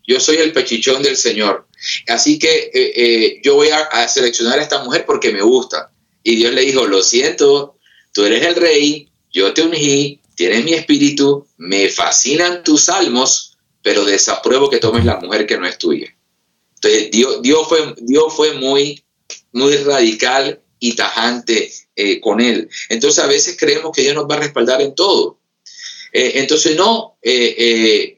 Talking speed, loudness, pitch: 175 wpm, -13 LUFS, 370 Hz